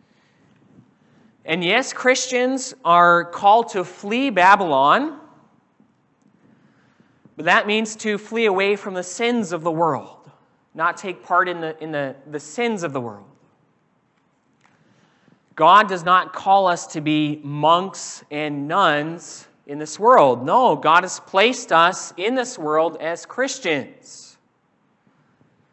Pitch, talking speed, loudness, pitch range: 180 Hz, 130 wpm, -19 LUFS, 155-220 Hz